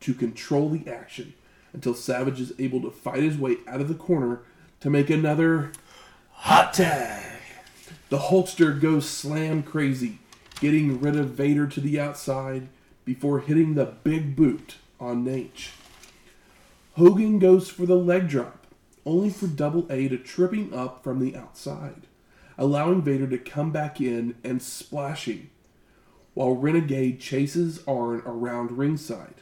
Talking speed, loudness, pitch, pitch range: 145 wpm, -24 LUFS, 145 Hz, 130-160 Hz